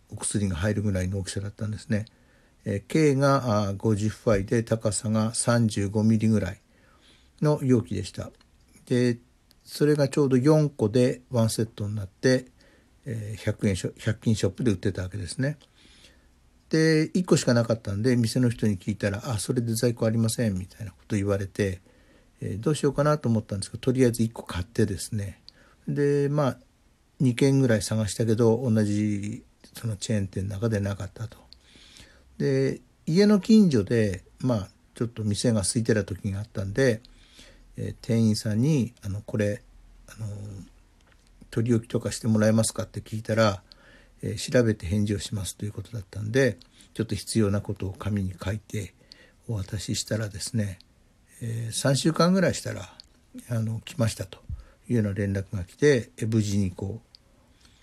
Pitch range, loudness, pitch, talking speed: 100-120 Hz, -26 LUFS, 110 Hz, 330 characters per minute